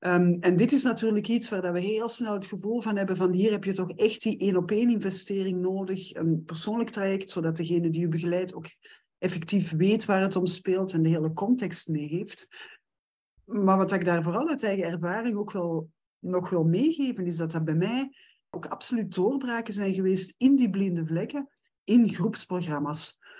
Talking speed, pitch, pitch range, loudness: 195 wpm, 190 Hz, 175-220 Hz, -27 LUFS